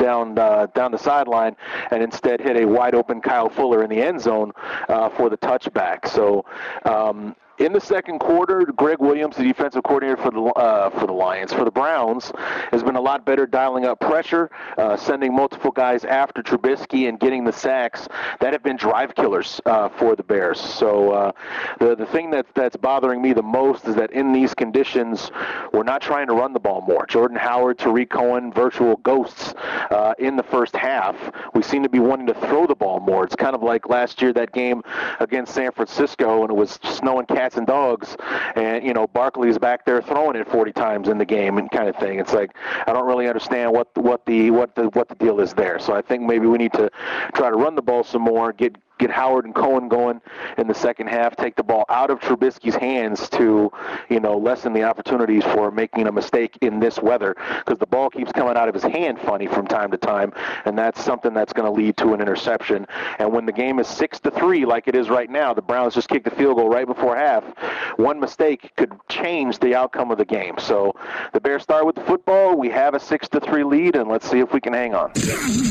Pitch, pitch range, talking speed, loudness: 120 Hz, 115-130 Hz, 225 wpm, -20 LUFS